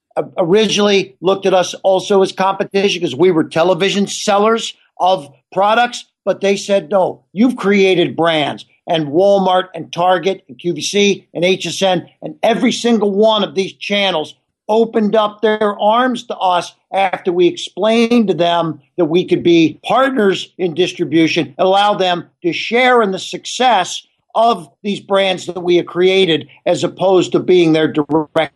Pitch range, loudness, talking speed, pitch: 175-205 Hz, -15 LUFS, 160 wpm, 190 Hz